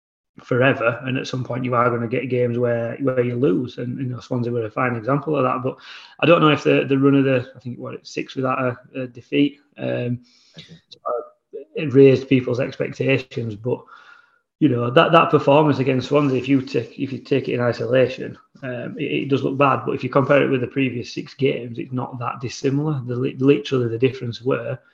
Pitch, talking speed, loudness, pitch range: 130 Hz, 220 wpm, -20 LUFS, 120-140 Hz